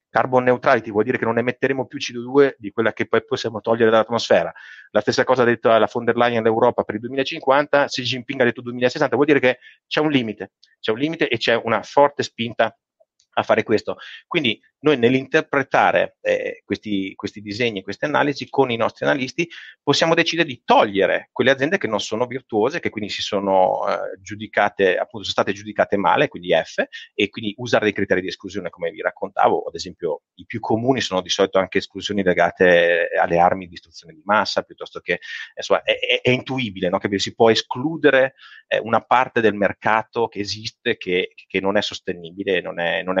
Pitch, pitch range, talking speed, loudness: 115 Hz, 100-145 Hz, 200 wpm, -20 LUFS